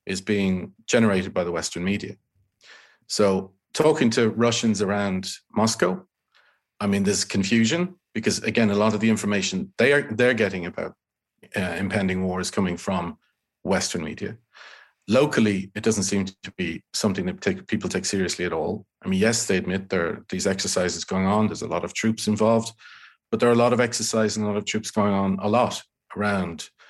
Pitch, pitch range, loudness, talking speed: 105 Hz, 100-115 Hz, -23 LUFS, 190 wpm